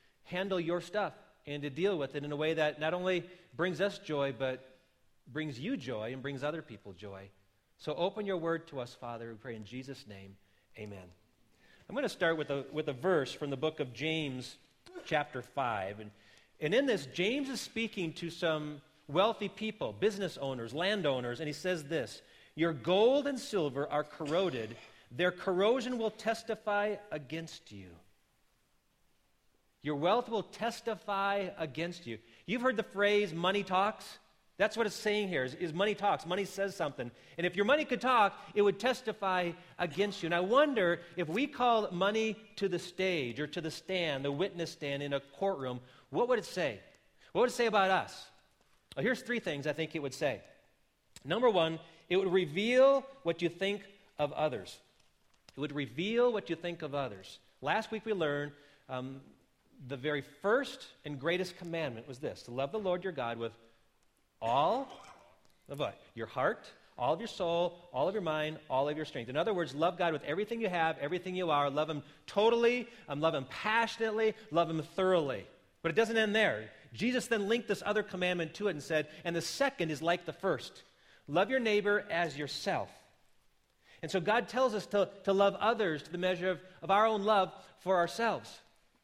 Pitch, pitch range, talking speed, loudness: 175 Hz, 145-205 Hz, 190 wpm, -33 LUFS